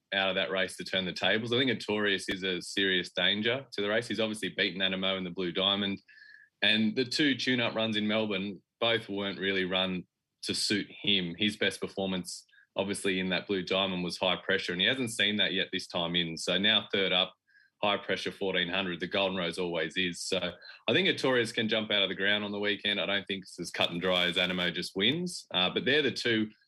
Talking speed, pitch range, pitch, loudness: 230 wpm, 90-105 Hz, 95 Hz, -29 LUFS